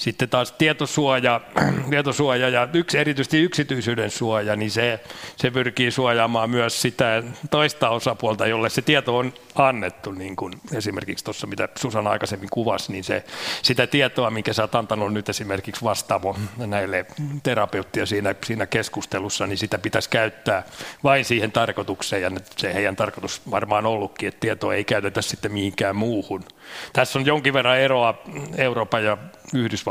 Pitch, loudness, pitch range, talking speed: 120 Hz, -22 LUFS, 110-135 Hz, 155 wpm